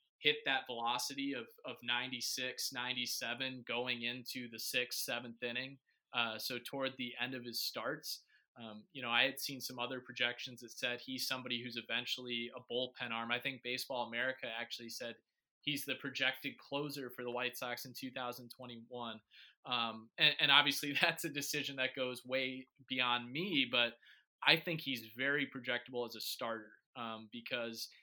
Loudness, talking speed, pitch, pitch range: -37 LUFS, 165 wpm, 125 Hz, 120-130 Hz